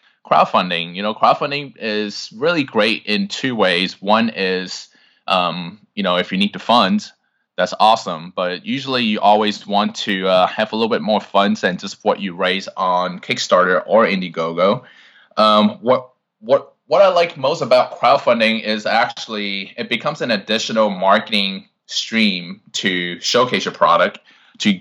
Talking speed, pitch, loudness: 160 wpm, 110 Hz, -17 LUFS